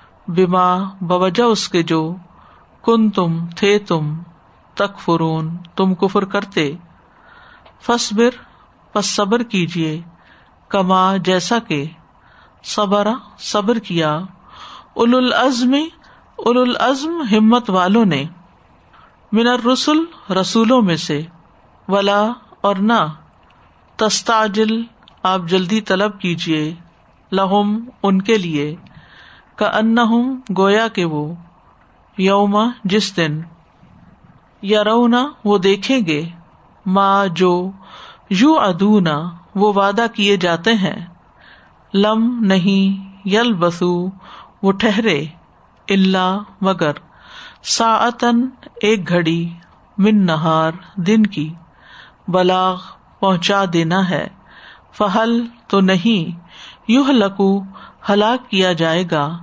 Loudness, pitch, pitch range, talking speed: -16 LUFS, 195 Hz, 175-225 Hz, 100 wpm